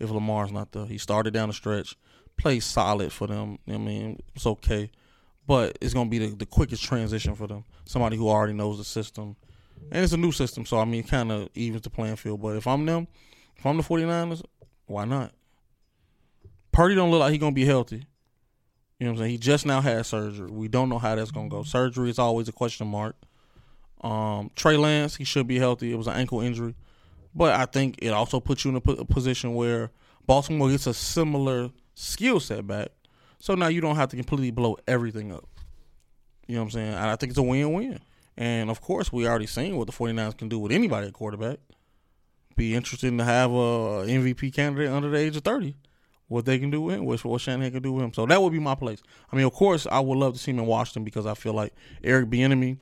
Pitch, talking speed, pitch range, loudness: 120 Hz, 235 wpm, 110-135 Hz, -26 LUFS